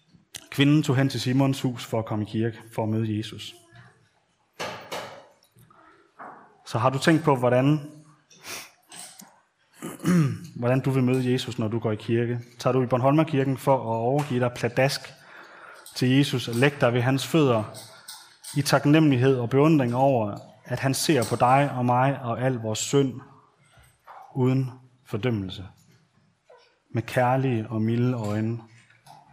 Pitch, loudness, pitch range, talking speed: 130 Hz, -24 LUFS, 115-135 Hz, 145 wpm